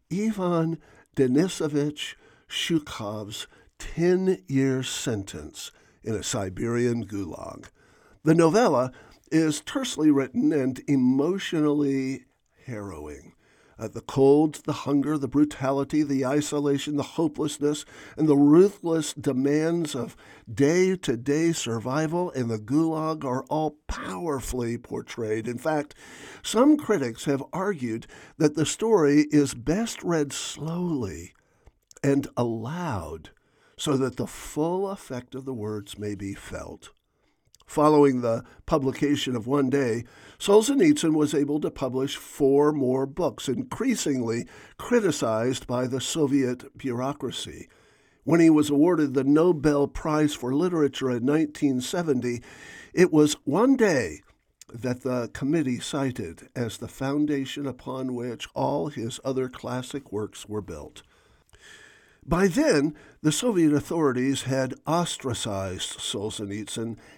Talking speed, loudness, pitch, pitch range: 115 wpm, -25 LUFS, 140 Hz, 125-155 Hz